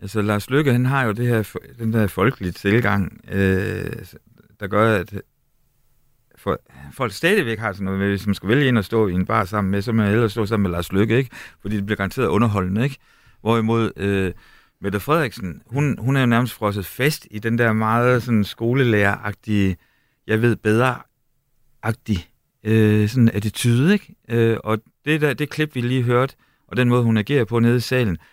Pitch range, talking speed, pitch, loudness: 105-125 Hz, 195 wpm, 110 Hz, -20 LUFS